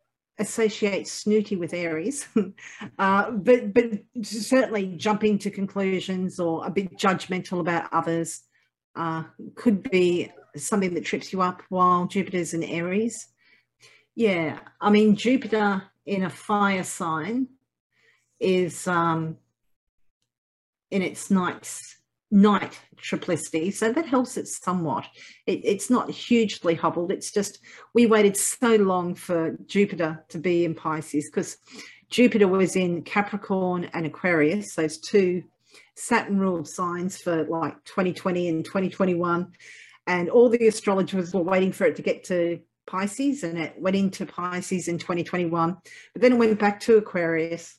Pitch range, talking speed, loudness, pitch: 170-210 Hz, 135 wpm, -24 LUFS, 185 Hz